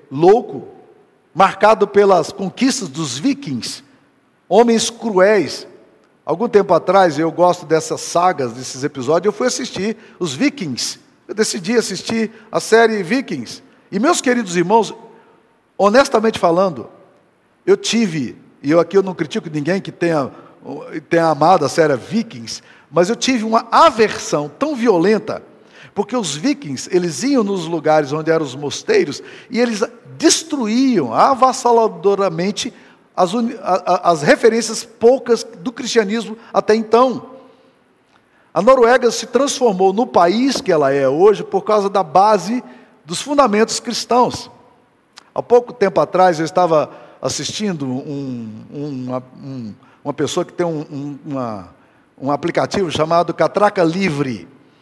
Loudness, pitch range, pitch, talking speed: -16 LUFS, 160-235 Hz, 200 Hz, 135 wpm